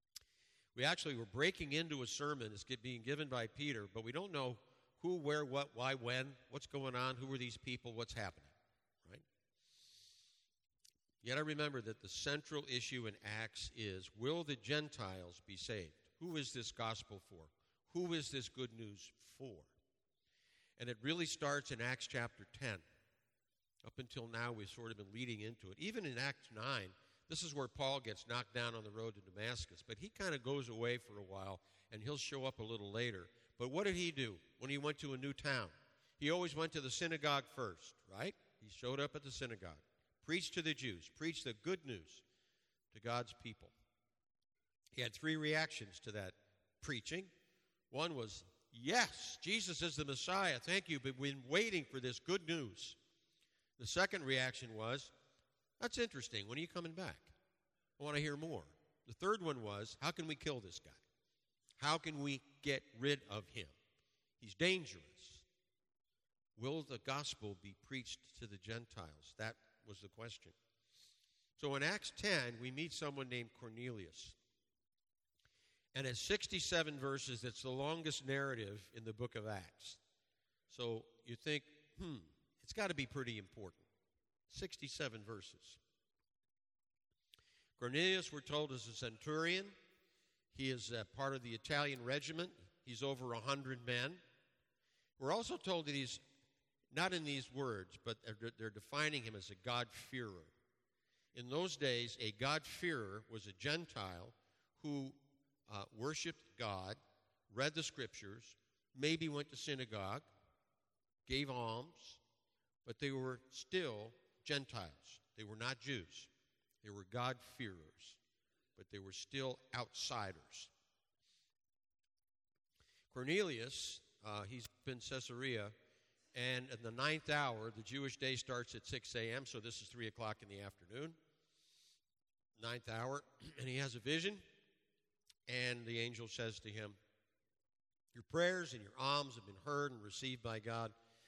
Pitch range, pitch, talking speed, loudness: 110-145 Hz, 125 Hz, 160 wpm, -44 LUFS